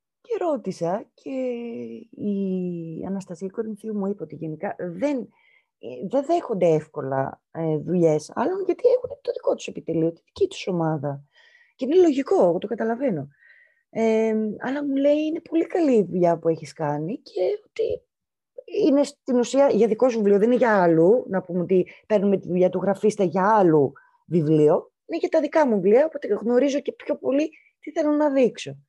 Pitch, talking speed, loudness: 230 Hz, 170 wpm, -23 LUFS